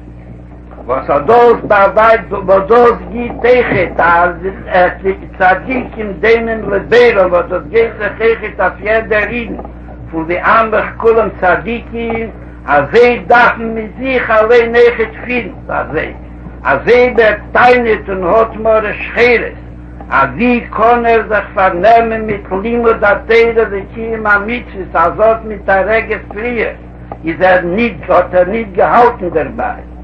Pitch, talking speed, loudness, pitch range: 220 Hz, 155 wpm, -11 LUFS, 185-230 Hz